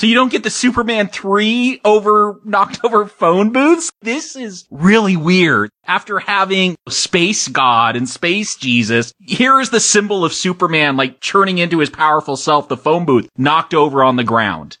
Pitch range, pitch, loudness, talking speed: 150-210 Hz, 185 Hz, -14 LUFS, 175 wpm